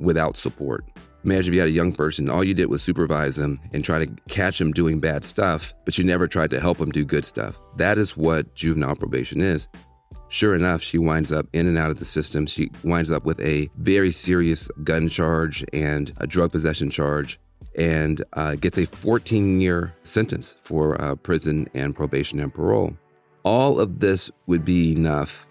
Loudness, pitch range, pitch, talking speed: -22 LUFS, 75-90 Hz, 80 Hz, 200 wpm